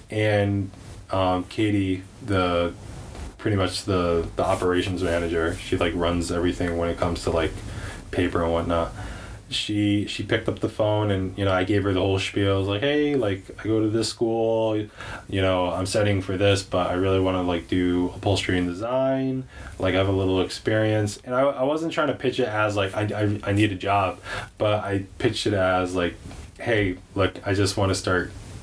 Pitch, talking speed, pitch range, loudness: 100 Hz, 205 wpm, 90-105 Hz, -24 LUFS